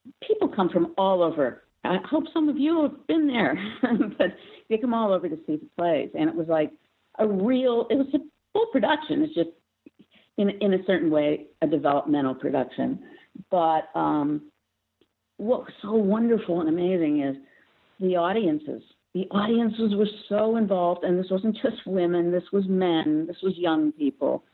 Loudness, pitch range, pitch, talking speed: -25 LUFS, 165-235 Hz, 190 Hz, 175 wpm